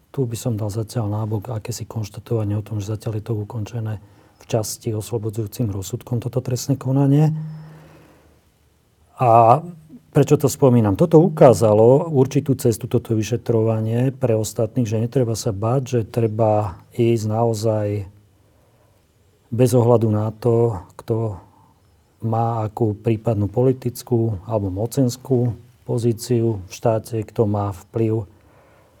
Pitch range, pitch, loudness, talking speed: 110-125 Hz, 115 Hz, -20 LUFS, 120 wpm